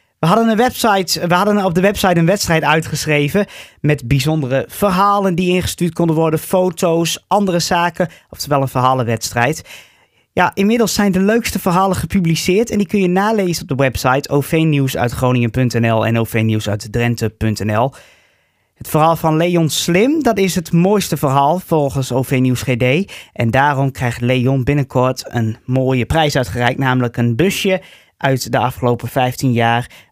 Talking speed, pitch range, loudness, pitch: 145 wpm, 125-185 Hz, -15 LUFS, 150 Hz